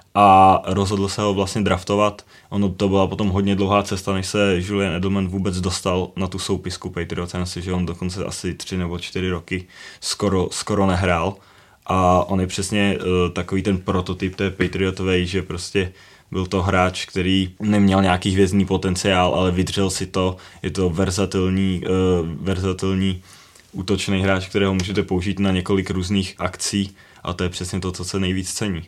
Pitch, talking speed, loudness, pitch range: 95 Hz, 170 wpm, -21 LUFS, 90-100 Hz